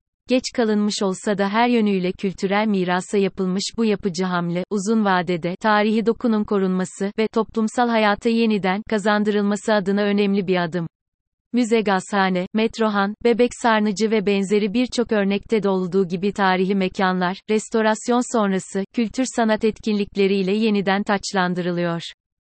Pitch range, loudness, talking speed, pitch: 190-220 Hz, -20 LUFS, 125 wpm, 205 Hz